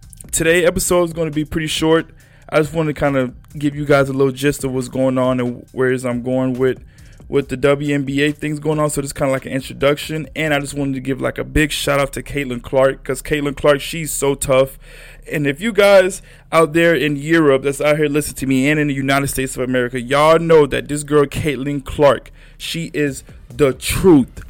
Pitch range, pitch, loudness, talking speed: 135-155 Hz, 145 Hz, -17 LUFS, 230 wpm